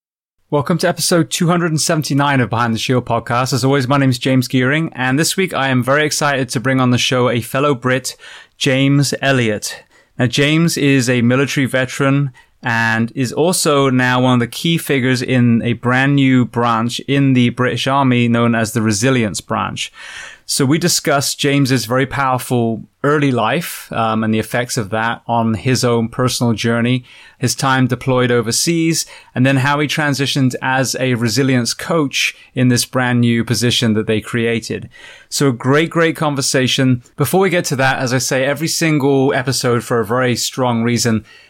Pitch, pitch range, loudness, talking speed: 130 Hz, 120-140 Hz, -15 LUFS, 180 wpm